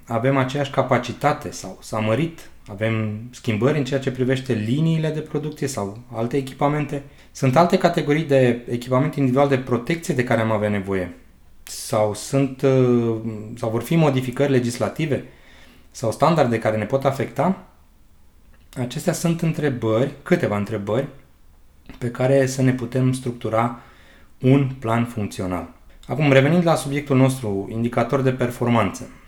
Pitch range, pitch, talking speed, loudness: 110-140 Hz, 125 Hz, 135 wpm, -21 LUFS